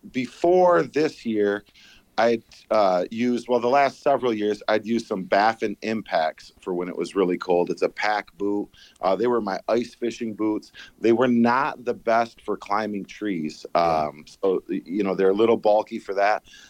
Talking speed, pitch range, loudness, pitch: 185 wpm, 100-120 Hz, -23 LUFS, 110 Hz